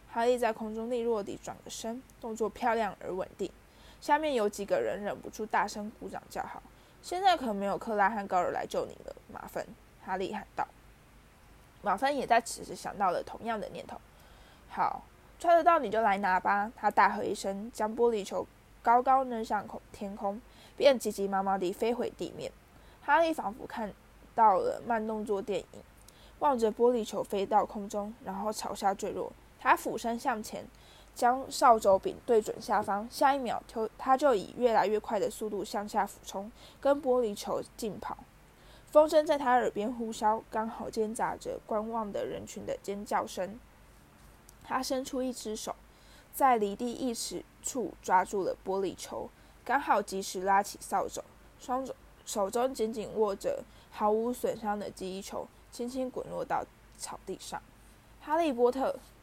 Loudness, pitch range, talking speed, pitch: -31 LUFS, 205-260 Hz, 245 characters per minute, 225 Hz